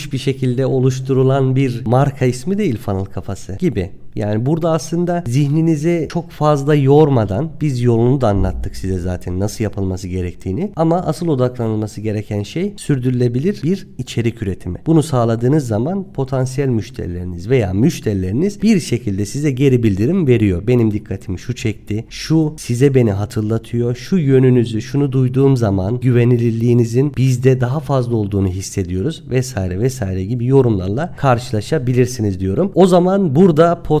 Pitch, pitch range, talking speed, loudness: 125 Hz, 105-150 Hz, 135 wpm, -16 LUFS